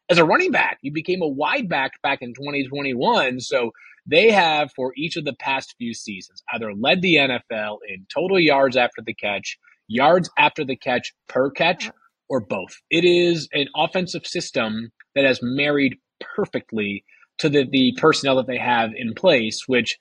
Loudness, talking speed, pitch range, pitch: -20 LUFS, 175 wpm, 120-155 Hz, 135 Hz